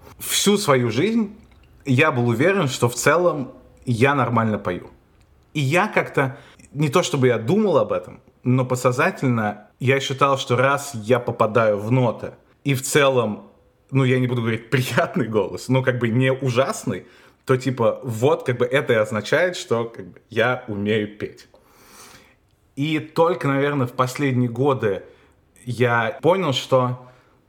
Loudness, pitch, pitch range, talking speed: -20 LUFS, 130 Hz, 120-140 Hz, 155 wpm